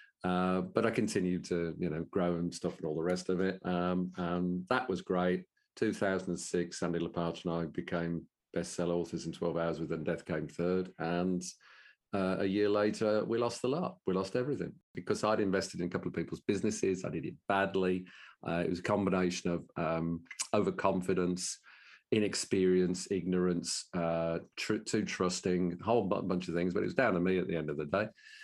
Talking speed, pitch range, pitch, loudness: 195 wpm, 85-95 Hz, 90 Hz, -34 LUFS